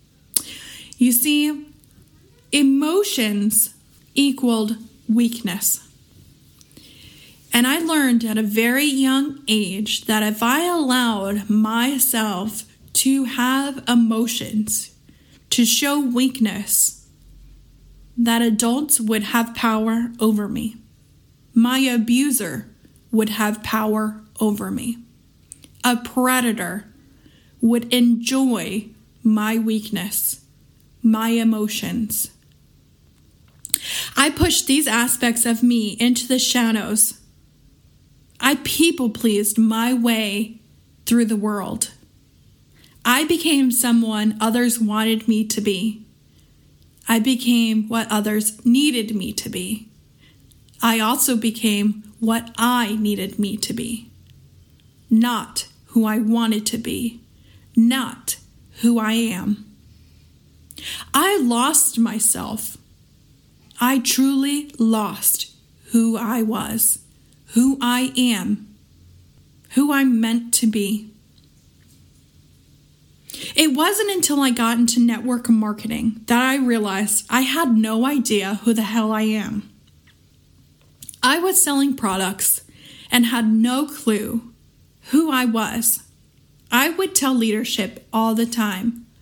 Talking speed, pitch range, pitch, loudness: 105 wpm, 220-250 Hz, 230 Hz, -19 LUFS